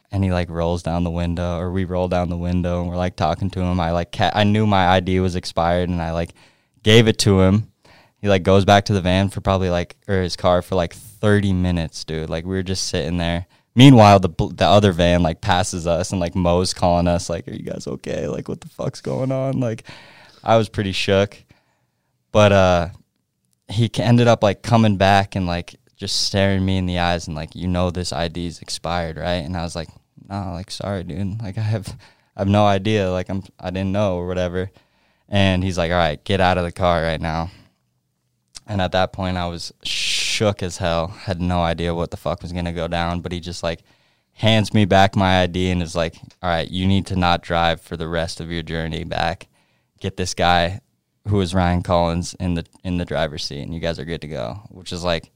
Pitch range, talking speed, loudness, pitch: 85-100 Hz, 230 wpm, -20 LUFS, 90 Hz